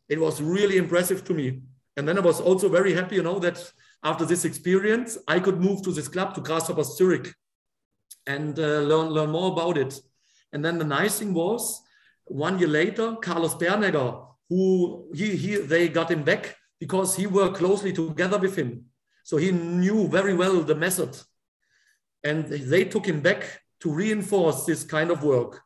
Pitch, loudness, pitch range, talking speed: 175 Hz, -24 LUFS, 155-190 Hz, 180 wpm